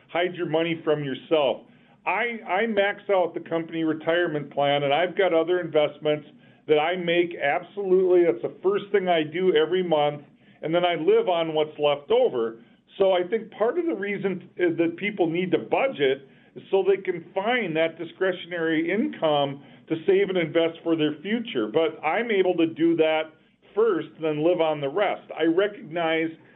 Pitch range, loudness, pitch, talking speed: 160-195 Hz, -24 LUFS, 175 Hz, 185 wpm